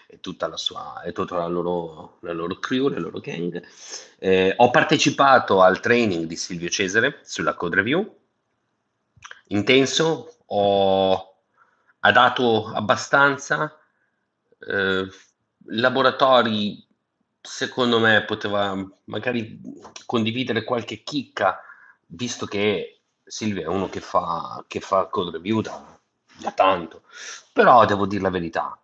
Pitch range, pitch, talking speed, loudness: 95-130 Hz, 110 Hz, 120 wpm, -21 LUFS